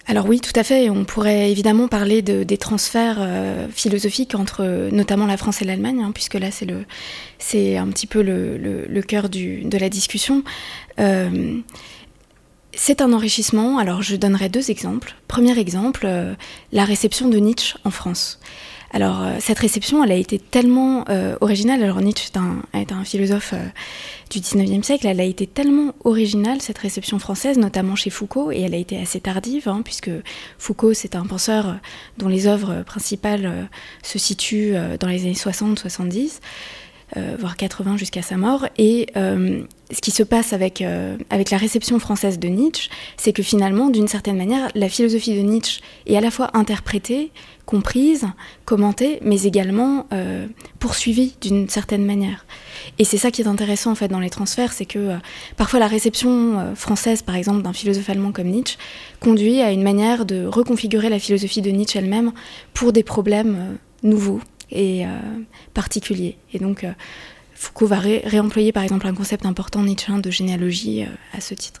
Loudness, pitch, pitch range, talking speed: -19 LUFS, 205 Hz, 195-225 Hz, 185 wpm